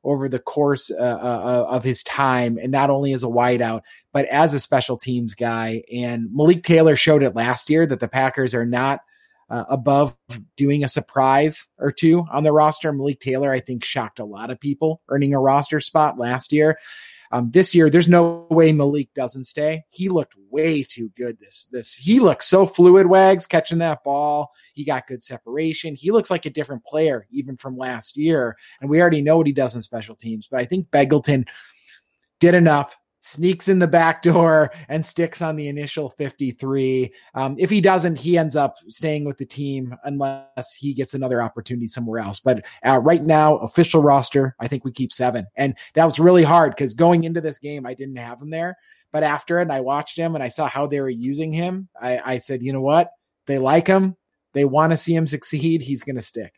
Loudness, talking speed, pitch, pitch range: -19 LUFS, 210 wpm, 140 Hz, 130-160 Hz